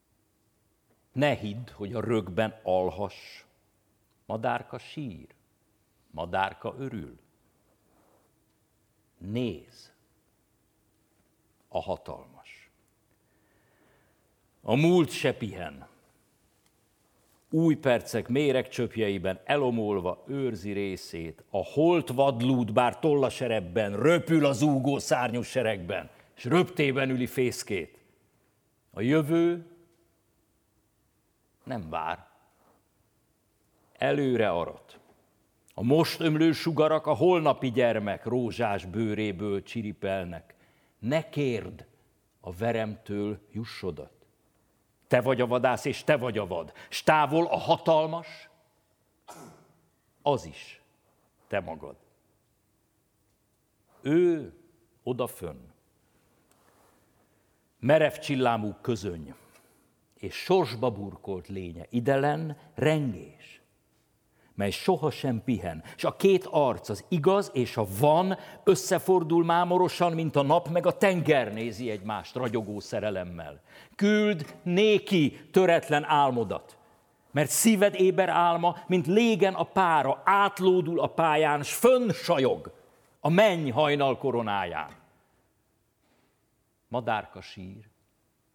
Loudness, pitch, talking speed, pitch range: -27 LUFS, 125 Hz, 90 wpm, 105-160 Hz